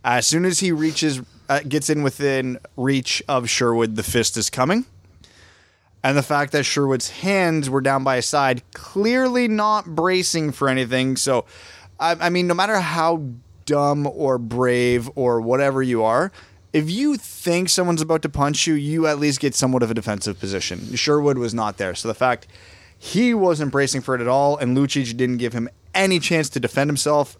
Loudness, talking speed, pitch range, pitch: -20 LUFS, 190 wpm, 120-155 Hz, 135 Hz